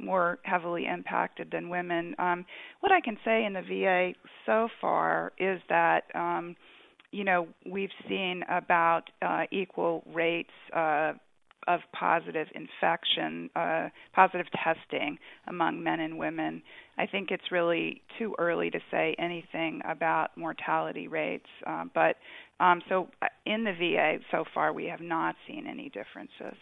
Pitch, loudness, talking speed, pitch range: 180 Hz, -30 LUFS, 145 wpm, 165-190 Hz